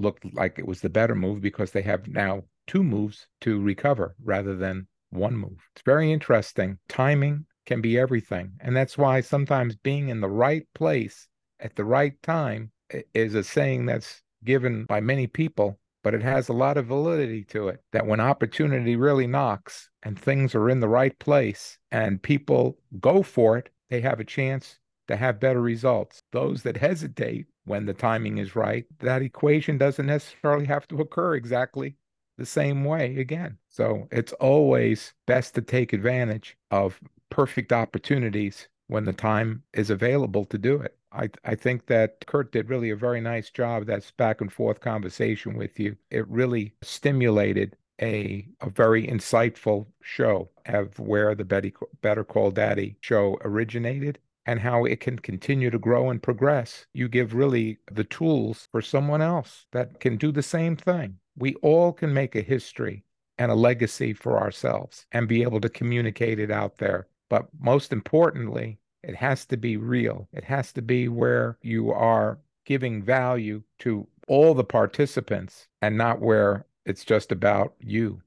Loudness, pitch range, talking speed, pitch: -25 LUFS, 105-135 Hz, 170 wpm, 120 Hz